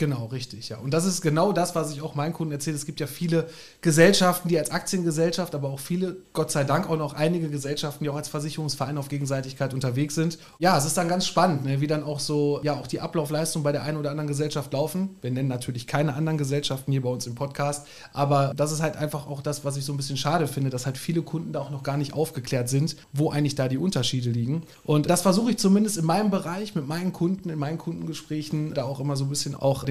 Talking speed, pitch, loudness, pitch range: 250 wpm, 150 Hz, -26 LUFS, 140-165 Hz